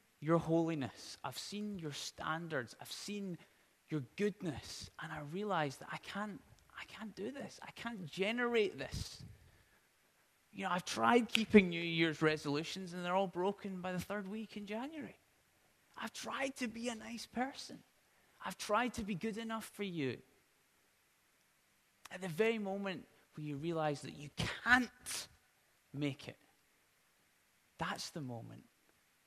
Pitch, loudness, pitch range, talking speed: 195 Hz, -39 LUFS, 160-220 Hz, 150 wpm